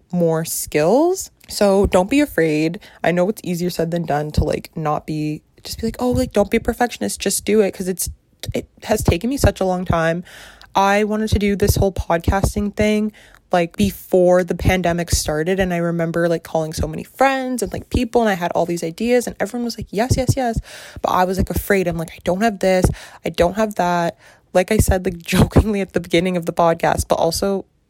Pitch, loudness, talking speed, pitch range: 180 Hz, -19 LUFS, 225 wpm, 165-210 Hz